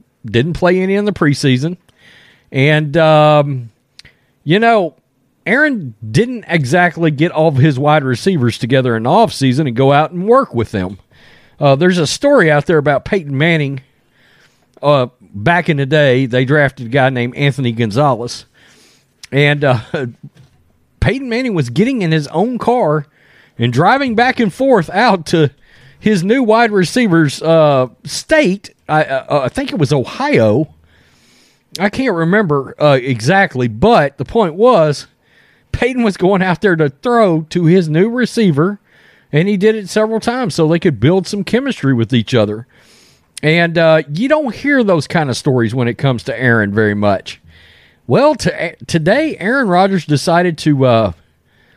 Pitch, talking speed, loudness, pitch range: 155 Hz, 160 wpm, -13 LUFS, 130-195 Hz